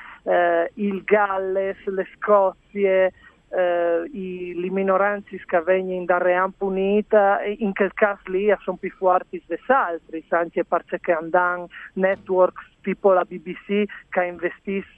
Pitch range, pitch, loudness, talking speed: 180-195 Hz, 185 Hz, -22 LUFS, 115 wpm